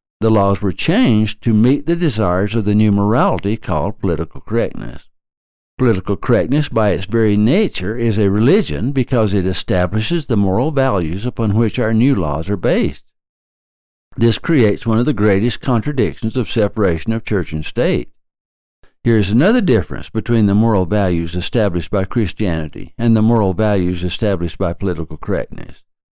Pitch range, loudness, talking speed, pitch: 95-115 Hz, -16 LUFS, 160 wpm, 105 Hz